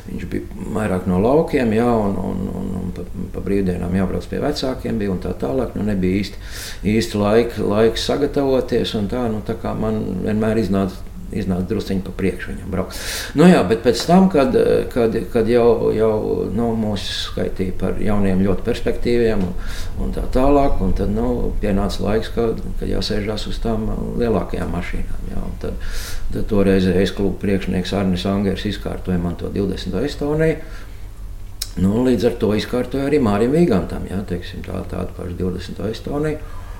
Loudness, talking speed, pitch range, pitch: -20 LUFS, 150 wpm, 90-110 Hz, 95 Hz